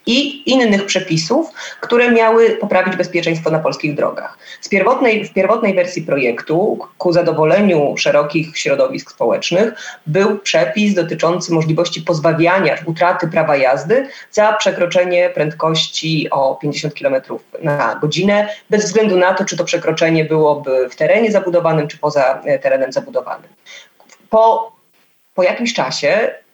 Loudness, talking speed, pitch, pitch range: -15 LUFS, 125 wpm, 180 Hz, 160-215 Hz